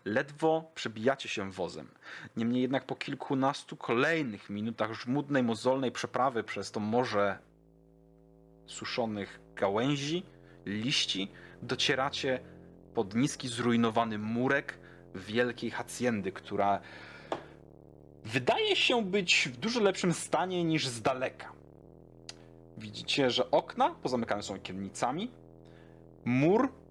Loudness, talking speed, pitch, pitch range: -31 LUFS, 100 wpm, 125 Hz, 105-145 Hz